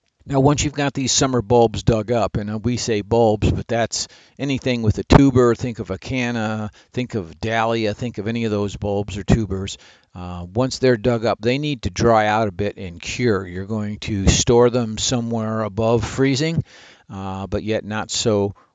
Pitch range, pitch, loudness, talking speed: 100-120 Hz, 110 Hz, -20 LUFS, 195 wpm